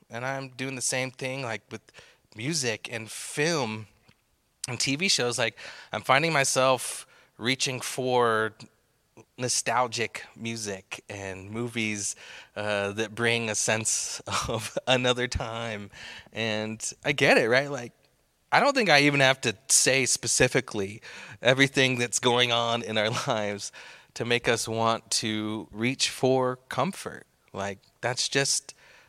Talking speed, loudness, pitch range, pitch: 135 wpm, -26 LUFS, 110-130 Hz, 120 Hz